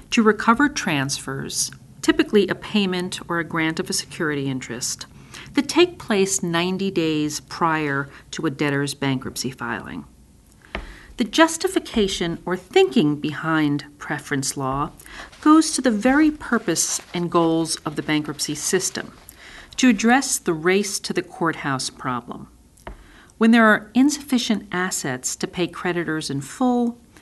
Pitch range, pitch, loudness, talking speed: 150-225 Hz, 175 Hz, -21 LUFS, 130 wpm